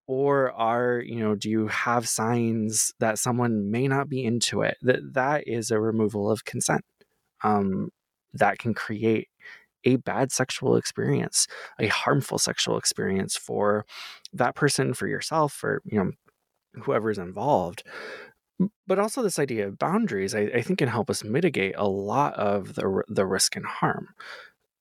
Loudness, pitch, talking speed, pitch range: -25 LUFS, 115 Hz, 155 wpm, 105-140 Hz